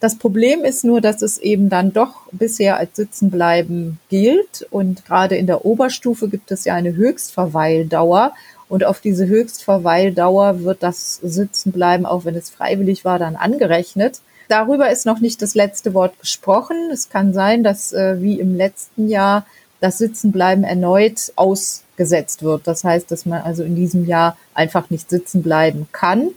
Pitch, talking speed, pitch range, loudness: 195 Hz, 160 wpm, 175-215 Hz, -16 LUFS